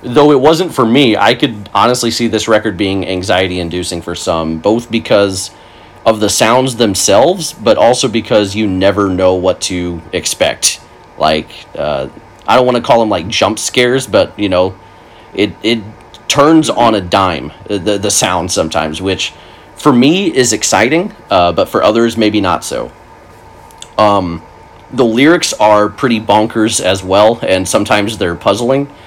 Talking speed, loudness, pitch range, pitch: 165 wpm, -11 LUFS, 95-115 Hz, 105 Hz